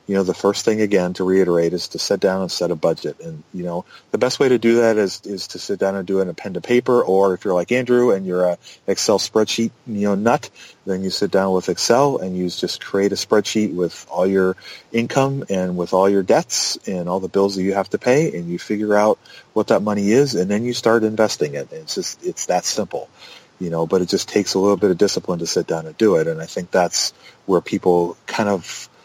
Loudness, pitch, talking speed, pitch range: -19 LUFS, 95 Hz, 260 wpm, 90-110 Hz